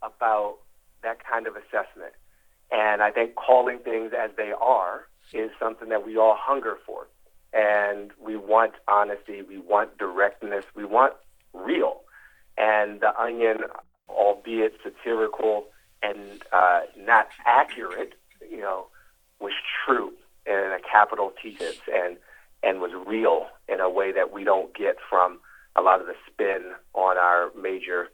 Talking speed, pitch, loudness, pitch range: 145 wpm, 110 Hz, -24 LUFS, 100-115 Hz